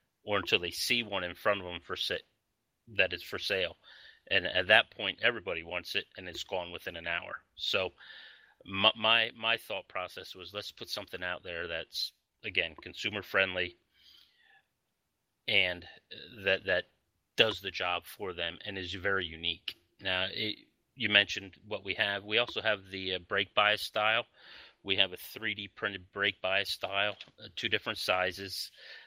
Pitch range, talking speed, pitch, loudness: 90-105 Hz, 165 wpm, 95 Hz, -31 LUFS